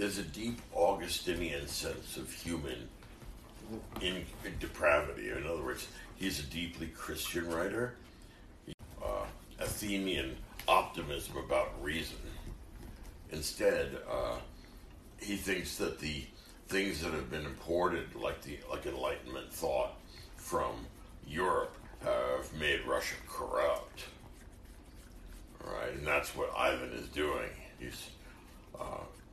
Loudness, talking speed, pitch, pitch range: -36 LUFS, 115 wpm, 85 Hz, 75-100 Hz